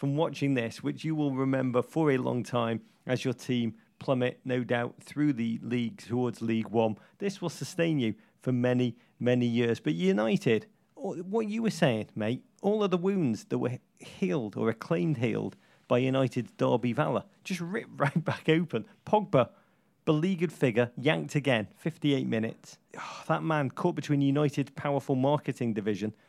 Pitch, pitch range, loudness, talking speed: 140 Hz, 120-165 Hz, -30 LUFS, 165 wpm